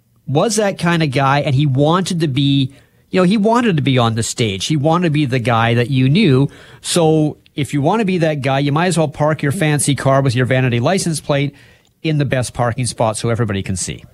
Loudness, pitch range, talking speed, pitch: -16 LUFS, 130-160 Hz, 245 wpm, 140 Hz